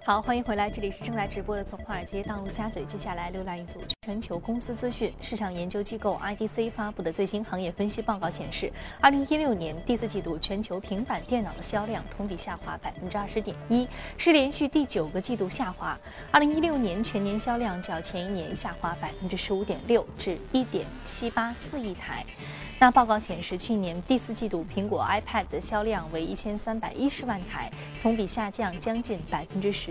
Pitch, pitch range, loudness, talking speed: 205 Hz, 185-230 Hz, -29 LUFS, 265 characters per minute